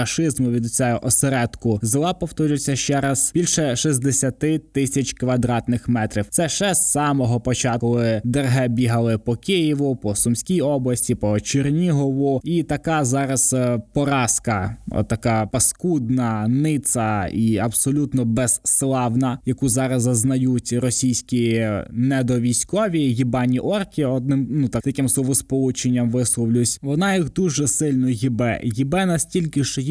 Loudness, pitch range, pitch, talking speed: -20 LUFS, 120-140 Hz, 130 Hz, 120 wpm